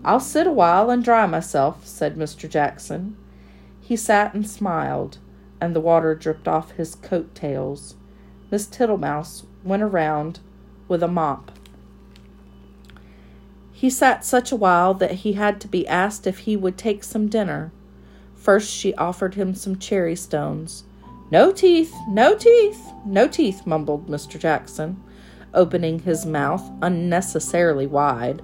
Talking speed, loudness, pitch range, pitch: 135 wpm, -20 LUFS, 150-205 Hz, 180 Hz